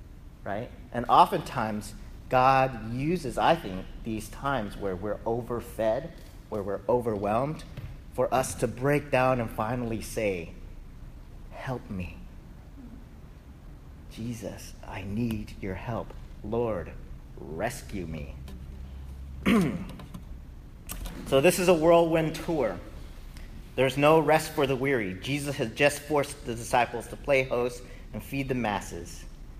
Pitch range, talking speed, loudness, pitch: 85-135 Hz, 120 wpm, -28 LUFS, 110 Hz